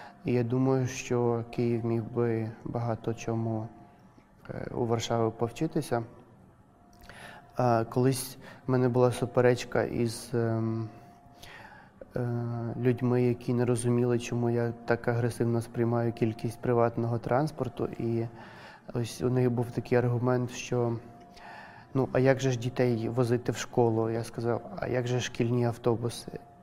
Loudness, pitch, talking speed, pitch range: -29 LUFS, 120 Hz, 120 wpm, 115-125 Hz